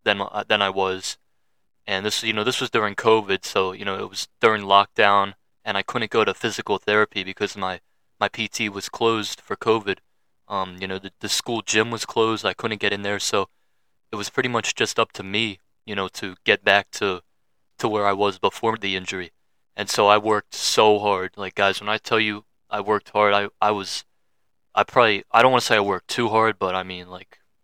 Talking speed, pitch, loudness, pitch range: 220 wpm, 100 Hz, -22 LUFS, 95-105 Hz